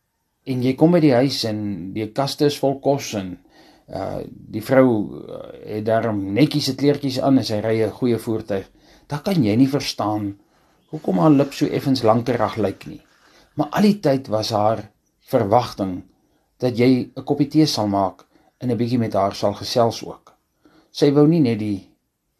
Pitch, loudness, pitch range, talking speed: 125 Hz, -20 LUFS, 105-140 Hz, 180 wpm